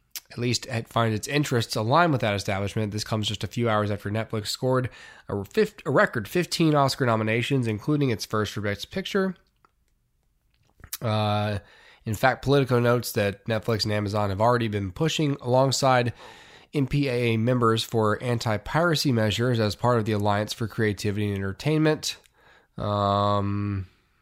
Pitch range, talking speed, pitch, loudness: 105-130 Hz, 150 wpm, 115 Hz, -25 LUFS